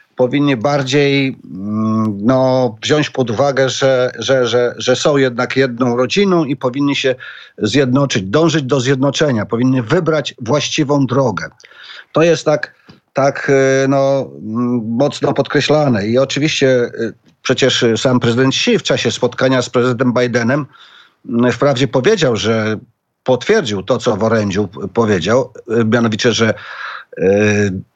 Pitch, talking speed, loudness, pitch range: 130 Hz, 120 wpm, -14 LUFS, 120-140 Hz